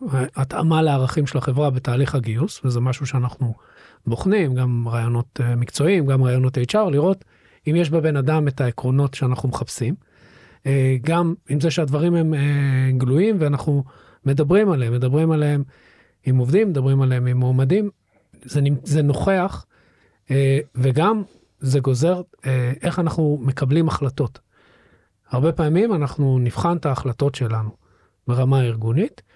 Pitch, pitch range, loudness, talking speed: 135 Hz, 125-155 Hz, -20 LUFS, 125 wpm